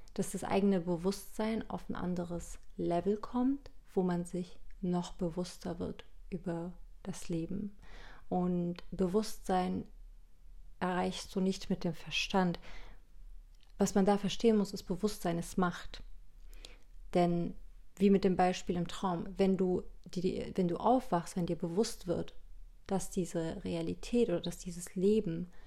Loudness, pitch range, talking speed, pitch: -35 LUFS, 175-200 Hz, 140 wpm, 185 Hz